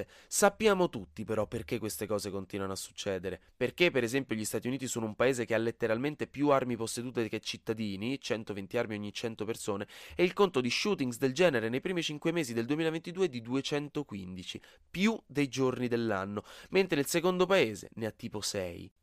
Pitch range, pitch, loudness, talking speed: 110-145 Hz, 120 Hz, -32 LUFS, 185 wpm